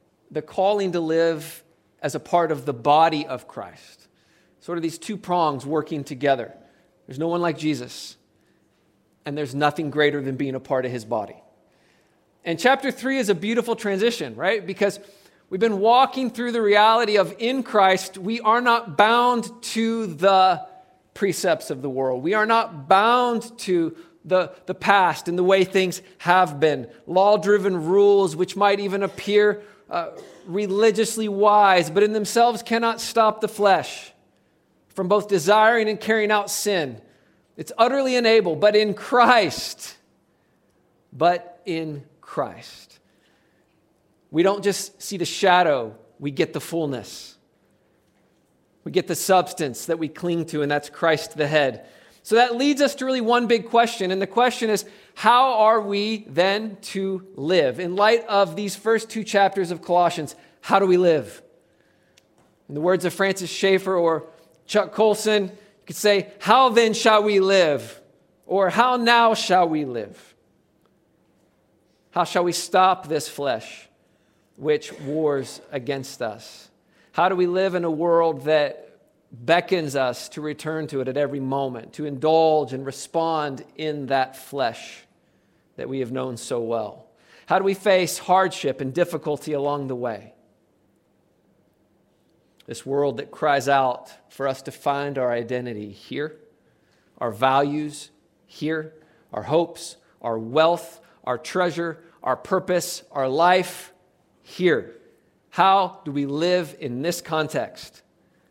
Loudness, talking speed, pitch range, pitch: -21 LUFS, 150 wpm, 150-205 Hz, 180 Hz